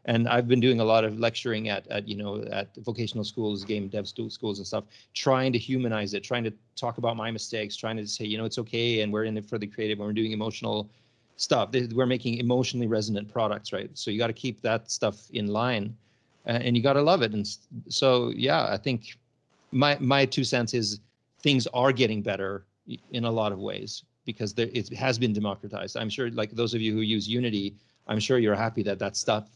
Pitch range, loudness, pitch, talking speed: 105-120 Hz, -27 LUFS, 115 Hz, 225 wpm